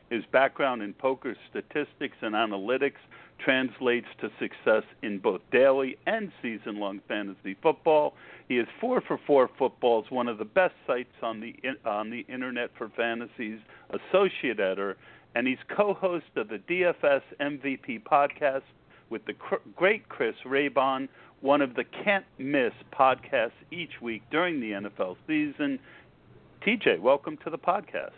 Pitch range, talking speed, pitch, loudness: 115-165 Hz, 145 wpm, 130 Hz, -28 LUFS